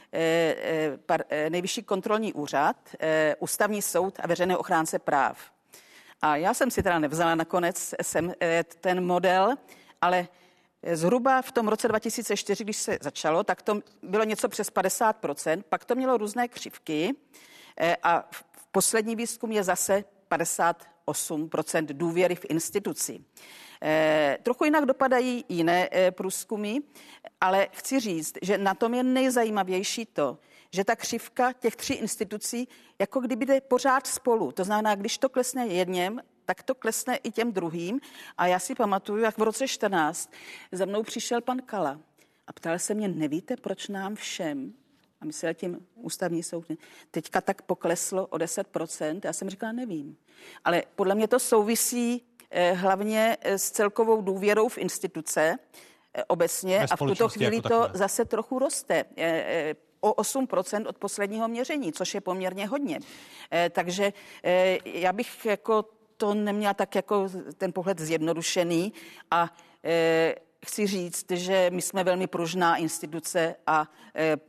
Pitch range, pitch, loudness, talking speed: 175-230 Hz, 195 Hz, -27 LUFS, 140 wpm